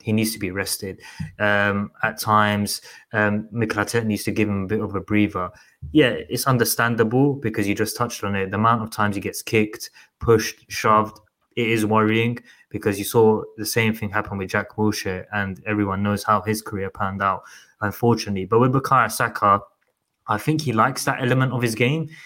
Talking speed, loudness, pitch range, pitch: 190 wpm, -21 LUFS, 105-115 Hz, 110 Hz